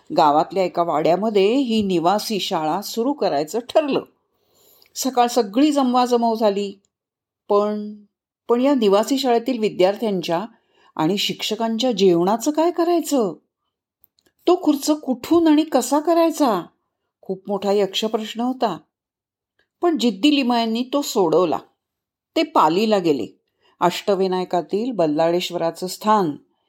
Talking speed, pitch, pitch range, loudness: 105 wpm, 225 Hz, 195-275 Hz, -20 LUFS